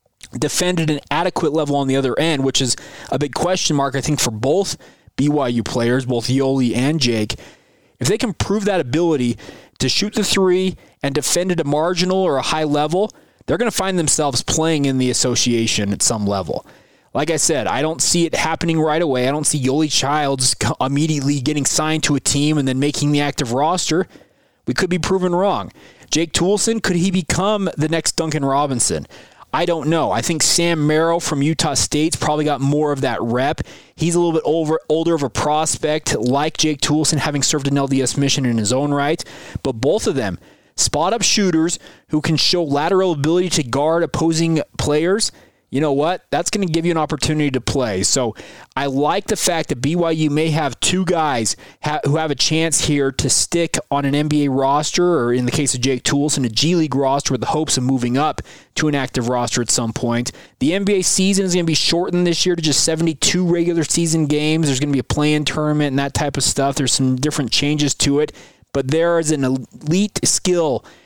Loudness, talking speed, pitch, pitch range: -18 LUFS, 210 wpm, 150 Hz, 135-165 Hz